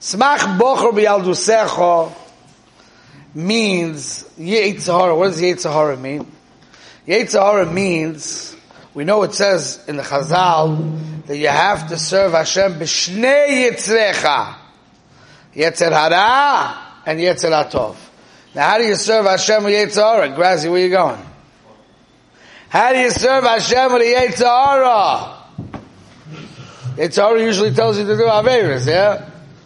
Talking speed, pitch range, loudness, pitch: 120 wpm, 155-215 Hz, -15 LUFS, 185 Hz